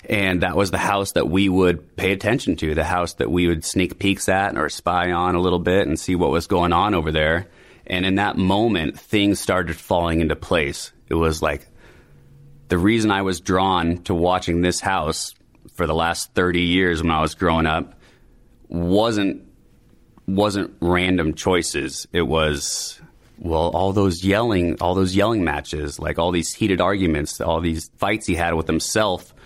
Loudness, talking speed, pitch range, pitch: -20 LUFS, 185 wpm, 85-95 Hz, 90 Hz